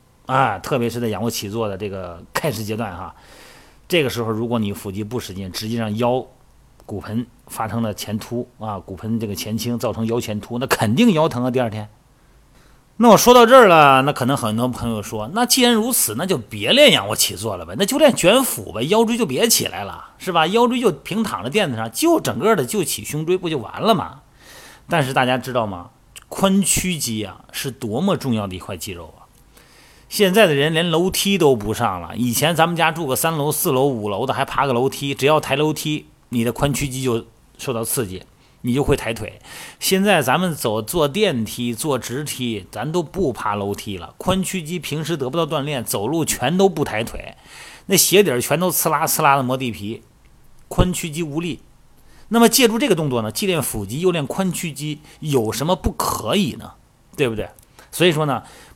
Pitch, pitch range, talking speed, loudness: 135 Hz, 115-170 Hz, 290 characters per minute, -19 LUFS